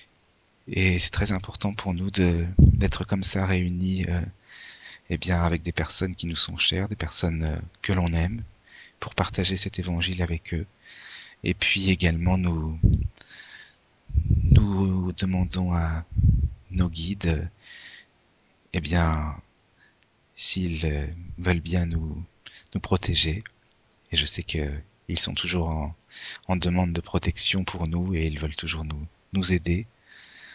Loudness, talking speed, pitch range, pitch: -24 LUFS, 140 wpm, 85-95 Hz, 90 Hz